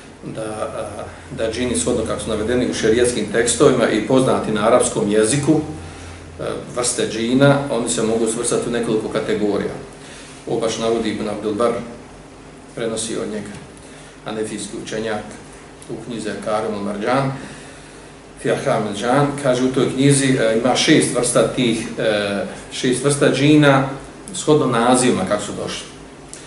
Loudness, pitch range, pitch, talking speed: -18 LUFS, 110-135 Hz, 120 Hz, 125 wpm